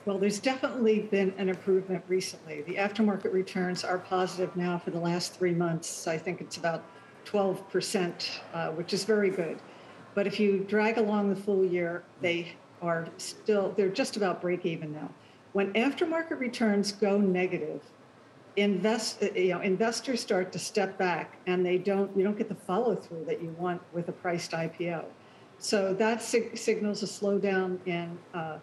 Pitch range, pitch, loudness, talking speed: 175-205 Hz, 190 Hz, -30 LUFS, 175 wpm